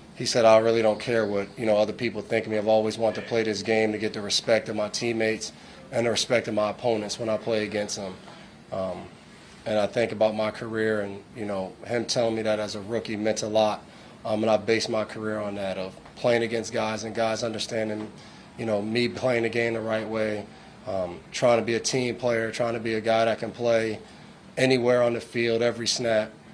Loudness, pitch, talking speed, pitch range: -26 LUFS, 110 Hz, 235 wpm, 105-115 Hz